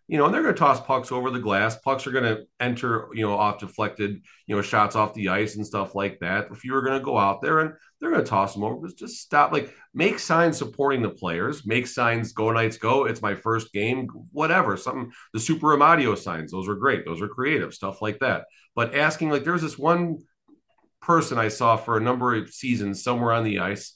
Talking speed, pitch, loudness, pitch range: 240 wpm, 115 Hz, -24 LUFS, 105-135 Hz